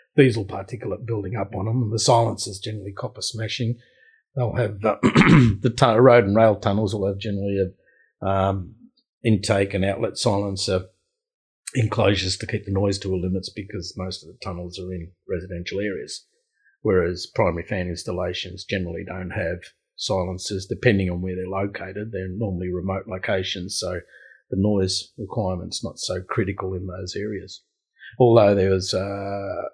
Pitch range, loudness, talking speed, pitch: 95-115 Hz, -23 LUFS, 155 wpm, 100 Hz